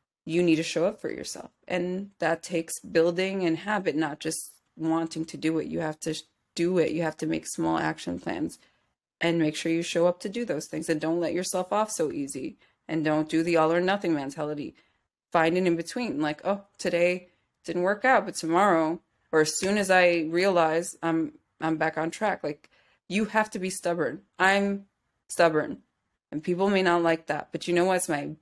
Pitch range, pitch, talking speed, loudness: 160-185 Hz, 165 Hz, 205 wpm, -27 LUFS